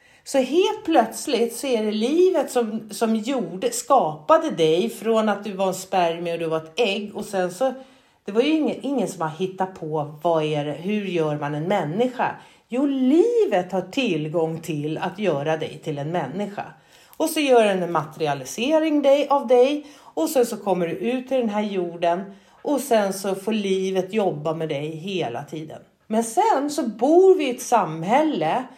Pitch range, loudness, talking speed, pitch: 170-255 Hz, -22 LUFS, 185 wpm, 210 Hz